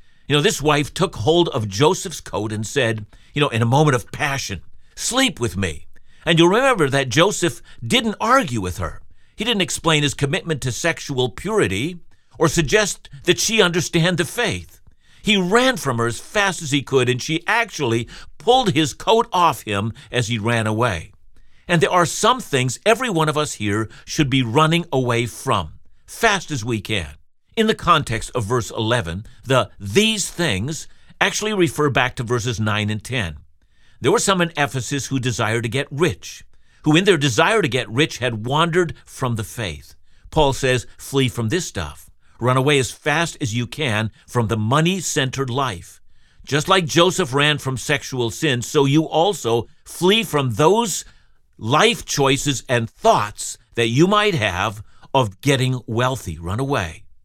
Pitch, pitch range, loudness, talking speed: 135 Hz, 110-165 Hz, -19 LUFS, 175 wpm